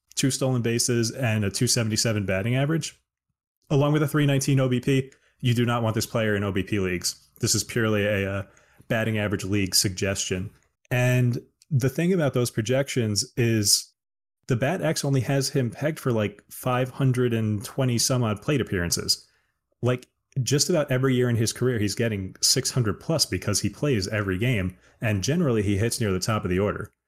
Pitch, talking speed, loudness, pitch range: 120 Hz, 175 wpm, -24 LUFS, 105-130 Hz